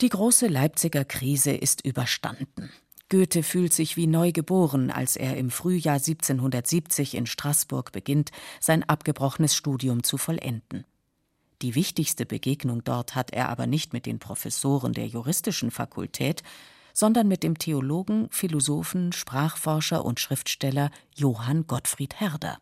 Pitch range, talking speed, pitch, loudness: 130-165 Hz, 135 wpm, 150 Hz, -25 LUFS